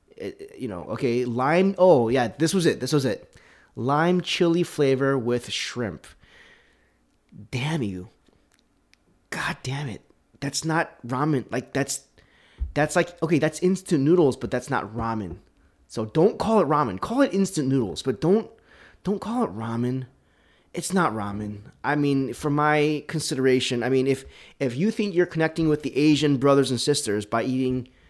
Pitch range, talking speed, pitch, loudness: 125-165 Hz, 160 wpm, 140 Hz, -24 LUFS